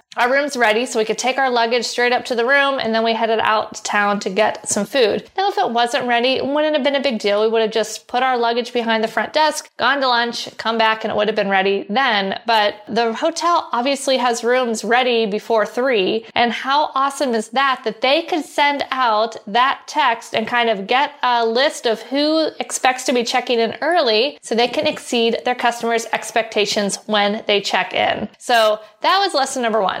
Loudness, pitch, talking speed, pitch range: -18 LUFS, 240 Hz, 225 wpm, 220-270 Hz